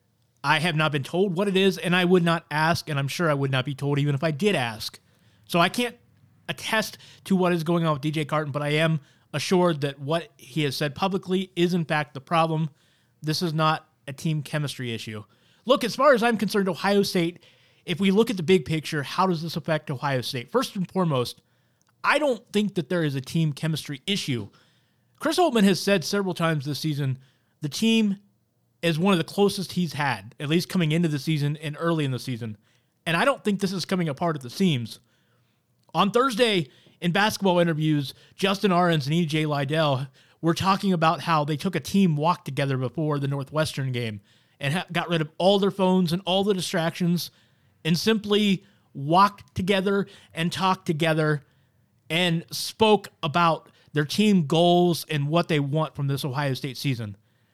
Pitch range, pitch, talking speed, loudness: 140-185 Hz, 160 Hz, 200 wpm, -24 LUFS